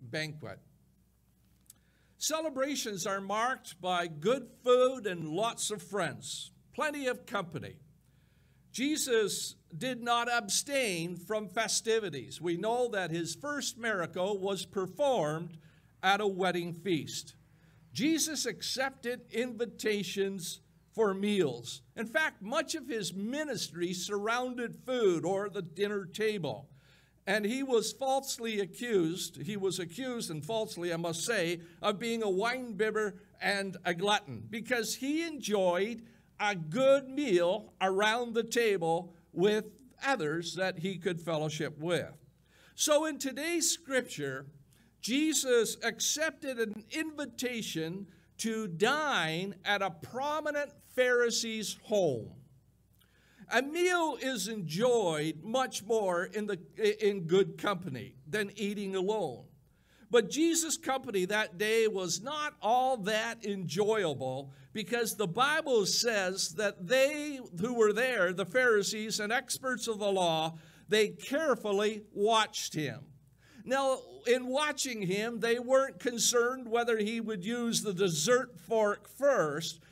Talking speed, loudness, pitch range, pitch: 120 wpm, -32 LUFS, 175-245 Hz, 210 Hz